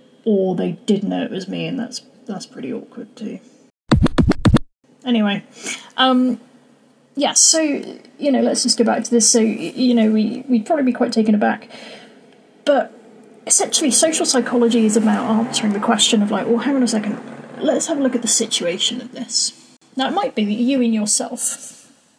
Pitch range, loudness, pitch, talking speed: 225-255 Hz, -17 LUFS, 240 Hz, 180 wpm